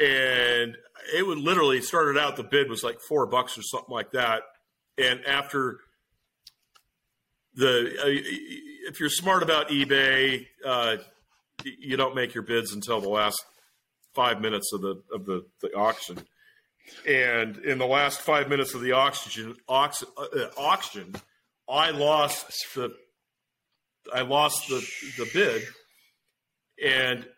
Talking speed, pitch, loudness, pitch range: 140 wpm, 130 Hz, -25 LUFS, 120-145 Hz